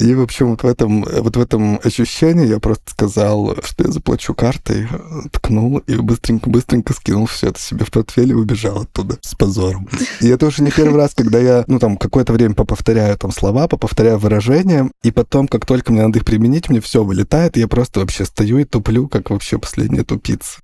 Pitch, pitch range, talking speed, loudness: 115 Hz, 110-130 Hz, 205 wpm, -15 LUFS